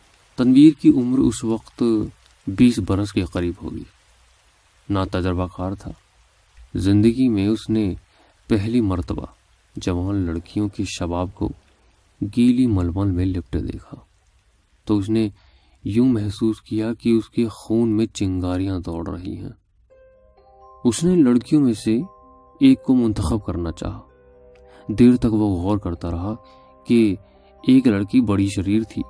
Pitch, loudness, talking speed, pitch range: 105 Hz, -20 LUFS, 140 wpm, 90-120 Hz